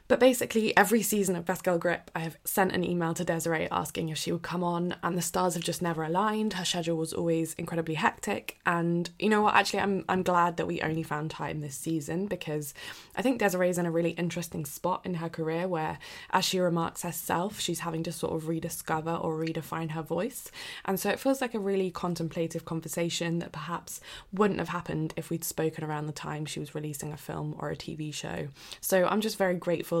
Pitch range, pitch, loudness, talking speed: 165-185 Hz, 170 Hz, -30 LUFS, 220 wpm